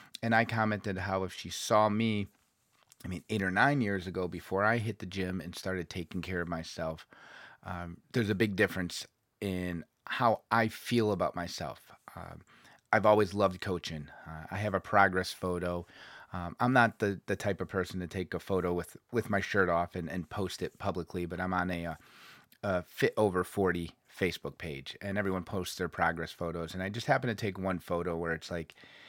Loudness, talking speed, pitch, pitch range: -32 LUFS, 200 wpm, 95 Hz, 90-105 Hz